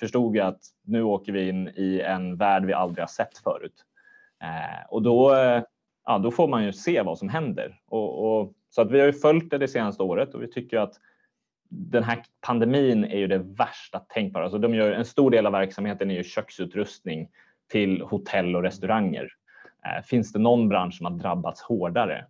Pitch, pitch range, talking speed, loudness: 110 Hz, 95-120 Hz, 195 wpm, -25 LUFS